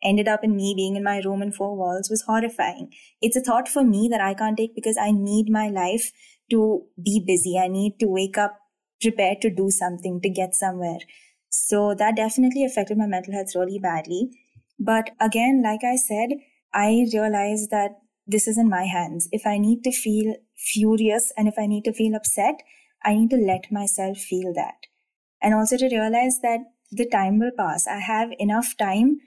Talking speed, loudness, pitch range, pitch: 200 wpm, -22 LUFS, 200-230 Hz, 215 Hz